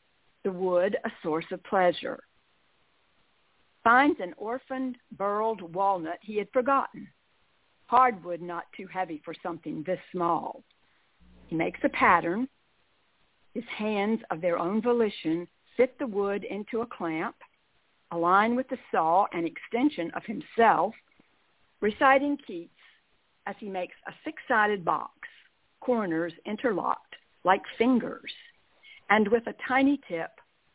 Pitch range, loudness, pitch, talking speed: 175-250 Hz, -28 LUFS, 210 Hz, 125 wpm